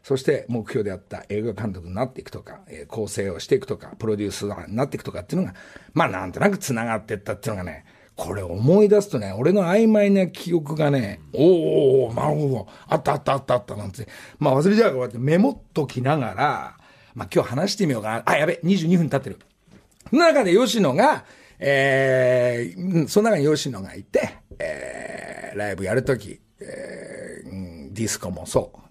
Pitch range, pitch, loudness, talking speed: 110-170 Hz, 135 Hz, -22 LUFS, 385 characters per minute